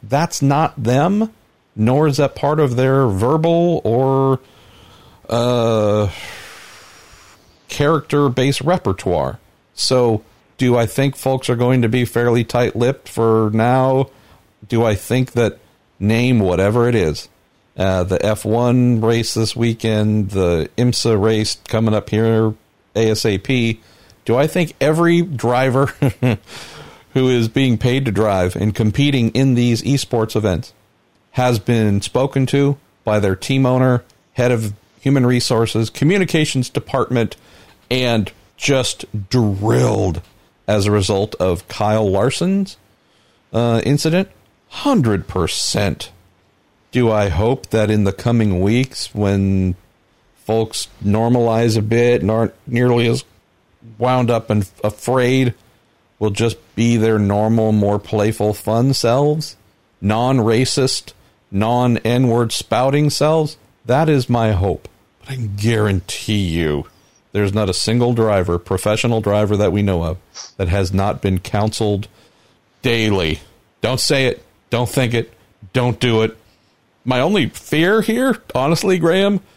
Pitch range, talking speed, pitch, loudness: 105-130 Hz, 125 wpm, 115 Hz, -17 LUFS